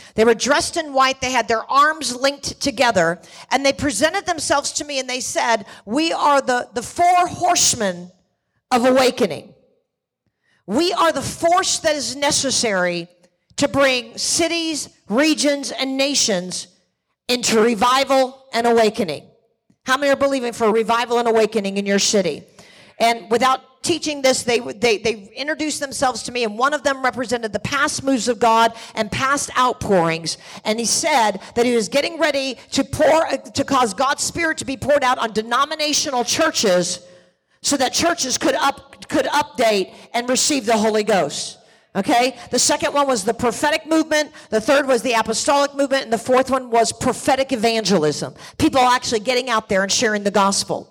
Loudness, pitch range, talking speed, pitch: -18 LUFS, 225-280 Hz, 170 wpm, 250 Hz